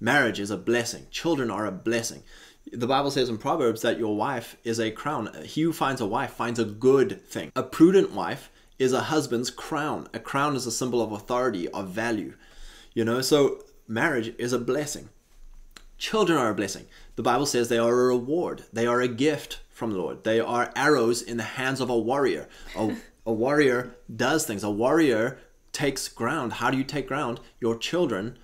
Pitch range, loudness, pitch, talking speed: 115-135 Hz, -26 LUFS, 120 Hz, 200 wpm